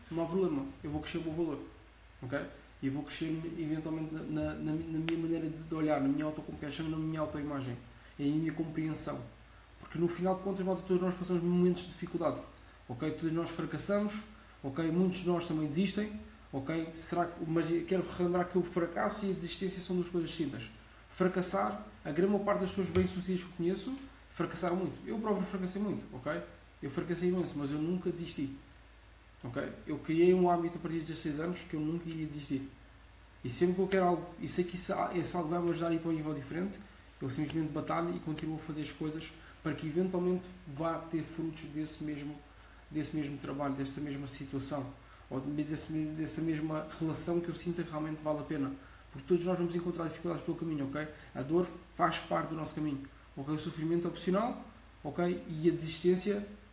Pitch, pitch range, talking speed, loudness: 160 Hz, 145-175 Hz, 200 wpm, -35 LUFS